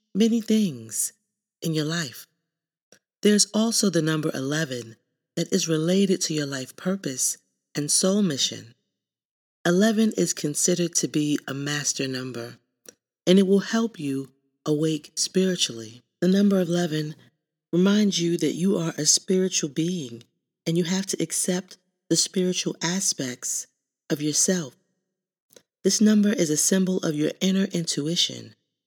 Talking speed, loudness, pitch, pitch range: 135 wpm, -23 LUFS, 170 Hz, 150-190 Hz